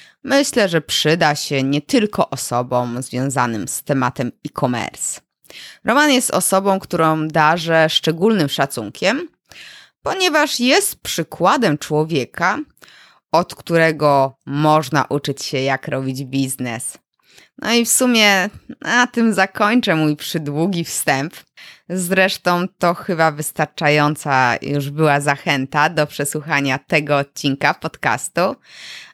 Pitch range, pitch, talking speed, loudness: 140-190 Hz, 155 Hz, 105 wpm, -17 LUFS